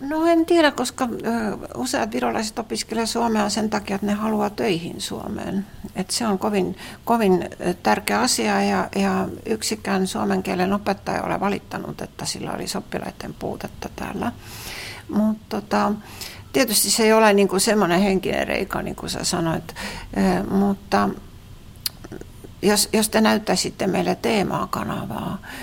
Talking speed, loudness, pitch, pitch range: 135 wpm, -22 LUFS, 210 Hz, 195-220 Hz